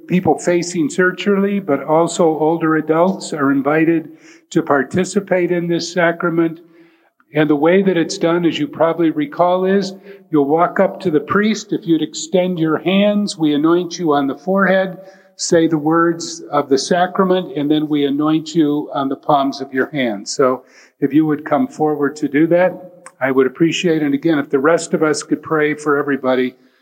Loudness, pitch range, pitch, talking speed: -16 LUFS, 150-180 Hz, 165 Hz, 185 wpm